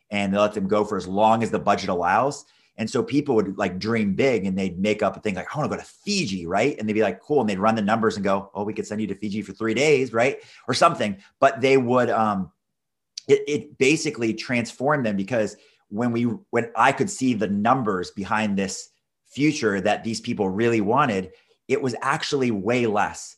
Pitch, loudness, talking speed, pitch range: 110 Hz, -23 LUFS, 230 wpm, 100-125 Hz